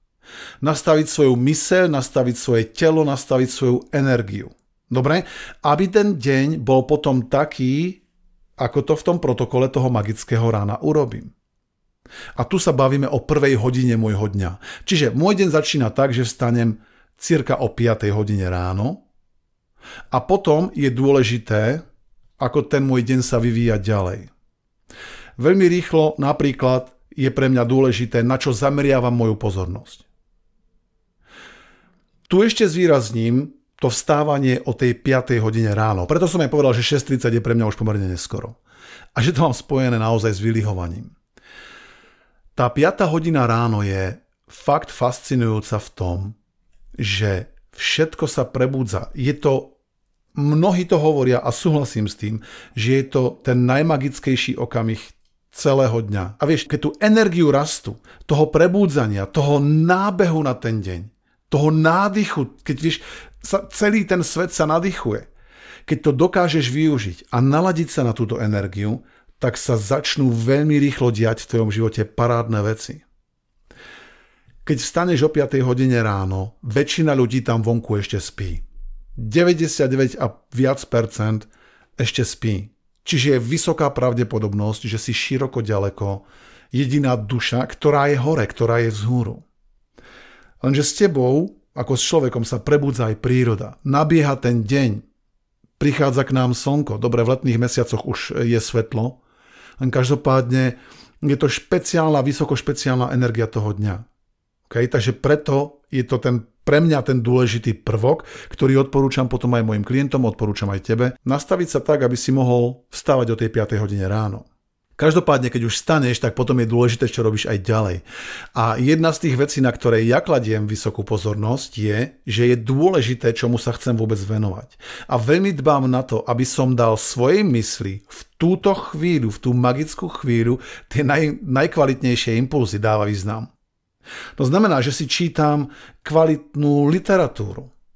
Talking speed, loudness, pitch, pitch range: 145 wpm, -19 LUFS, 125 Hz, 115-145 Hz